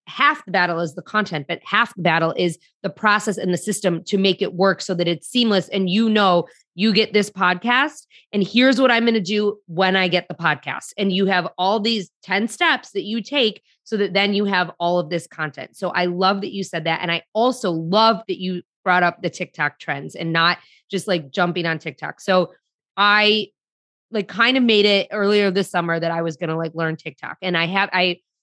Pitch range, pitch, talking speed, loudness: 175-210 Hz, 190 Hz, 230 wpm, -20 LUFS